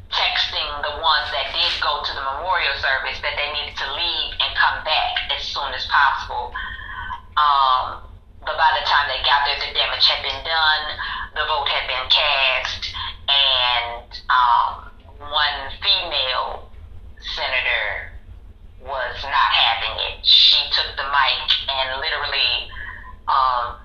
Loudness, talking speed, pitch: -18 LUFS, 140 wpm, 130 Hz